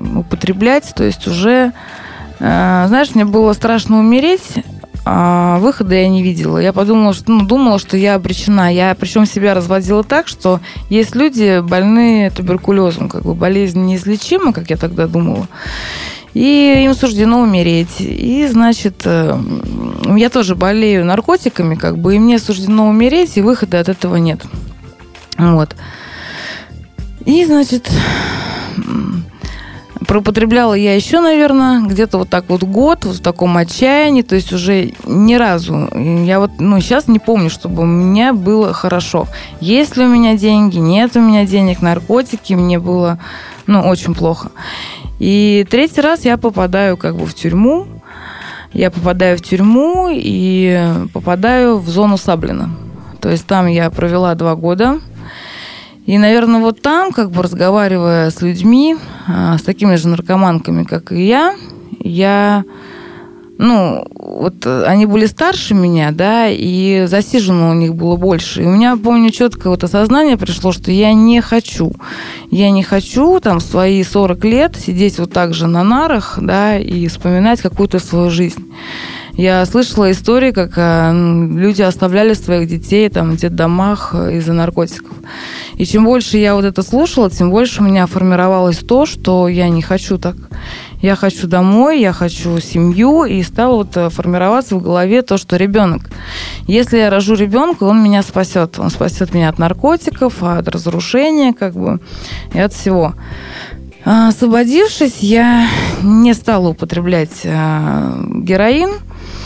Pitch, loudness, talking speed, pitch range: 195 Hz, -12 LUFS, 145 wpm, 180-230 Hz